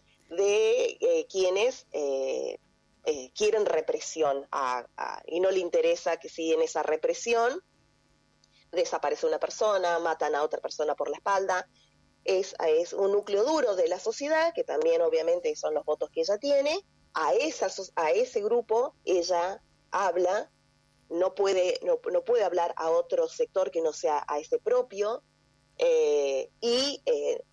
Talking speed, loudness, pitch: 155 wpm, -28 LUFS, 390 Hz